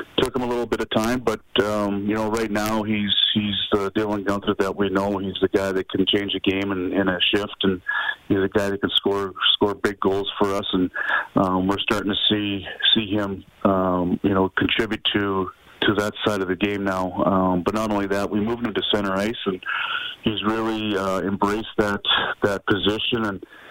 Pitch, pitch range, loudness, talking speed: 100 Hz, 95-105 Hz, -22 LUFS, 215 wpm